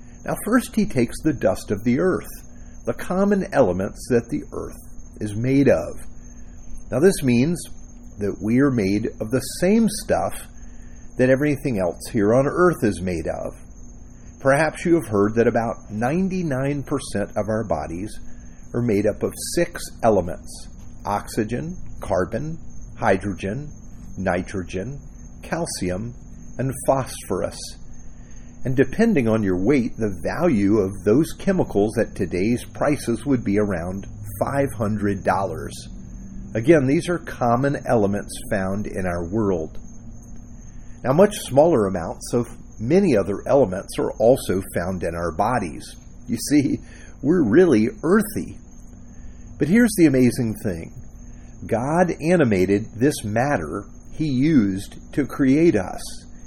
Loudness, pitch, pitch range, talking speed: -21 LUFS, 115 Hz, 100-145 Hz, 130 wpm